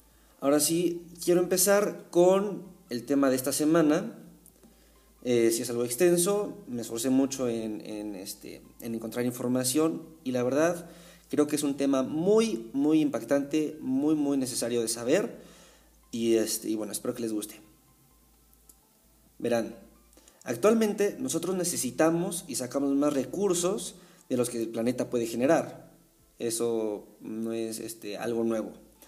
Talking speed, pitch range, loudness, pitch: 140 wpm, 115-170 Hz, -28 LUFS, 135 Hz